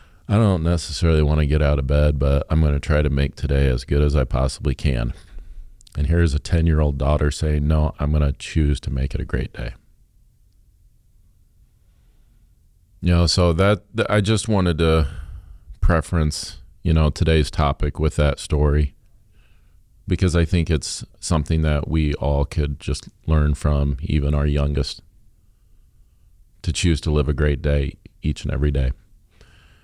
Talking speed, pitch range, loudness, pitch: 170 wpm, 75-90 Hz, -21 LUFS, 80 Hz